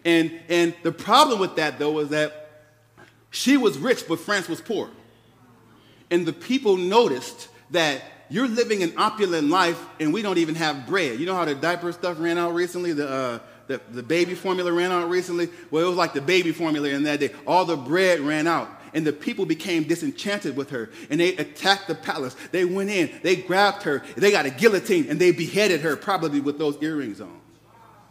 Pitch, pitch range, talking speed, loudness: 170 Hz, 150-185 Hz, 205 wpm, -23 LUFS